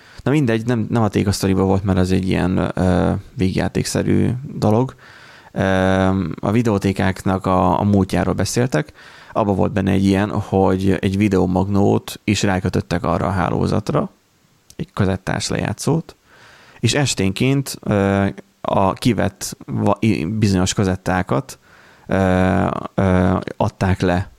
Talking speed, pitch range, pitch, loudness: 110 wpm, 95-105 Hz, 95 Hz, -18 LUFS